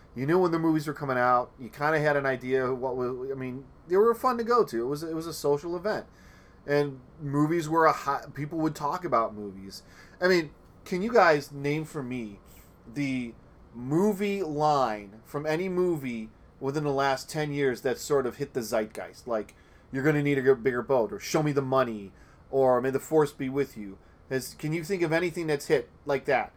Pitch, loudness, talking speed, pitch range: 140 Hz, -28 LUFS, 215 wpm, 125-155 Hz